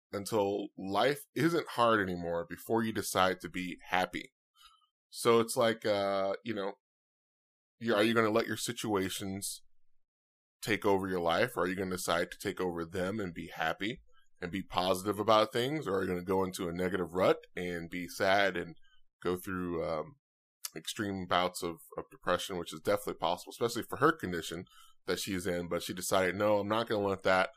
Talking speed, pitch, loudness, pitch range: 195 wpm, 95 Hz, -33 LUFS, 90-105 Hz